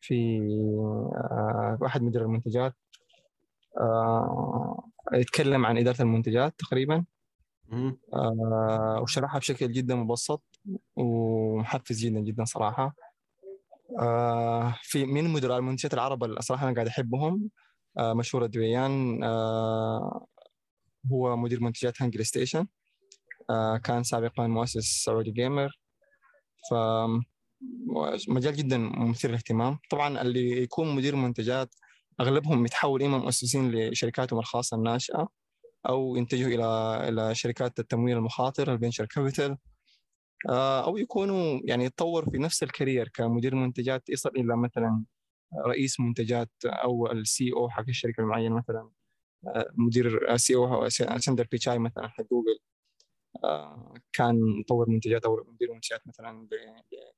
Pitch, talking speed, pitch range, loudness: 120 Hz, 110 wpm, 115-135 Hz, -28 LUFS